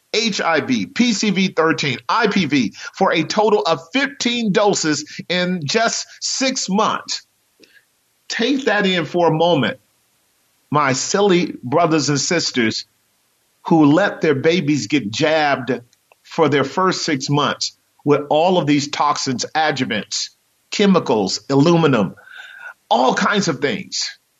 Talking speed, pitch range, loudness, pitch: 115 wpm, 145-210 Hz, -17 LUFS, 165 Hz